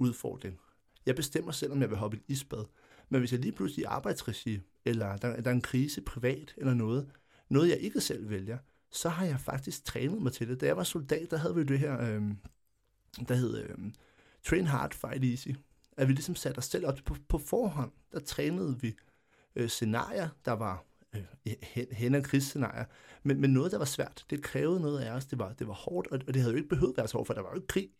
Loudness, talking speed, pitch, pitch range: -33 LUFS, 235 wpm, 130 Hz, 115-140 Hz